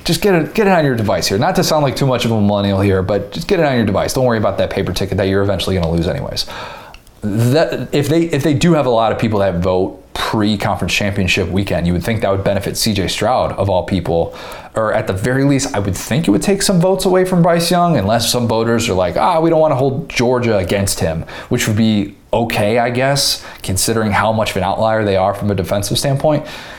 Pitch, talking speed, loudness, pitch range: 110 Hz, 255 wpm, -15 LUFS, 100-140 Hz